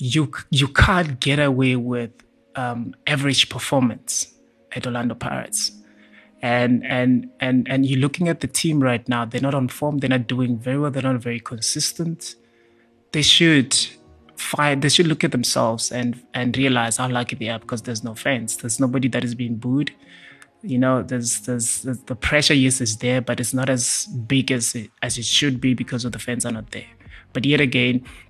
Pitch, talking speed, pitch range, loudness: 125 Hz, 195 wpm, 120-135 Hz, -20 LUFS